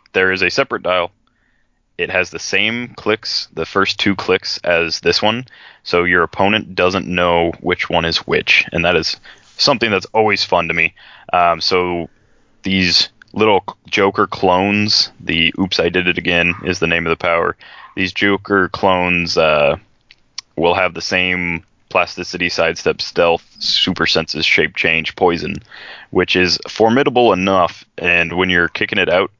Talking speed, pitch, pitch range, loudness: 160 wpm, 90 Hz, 85-95 Hz, -15 LUFS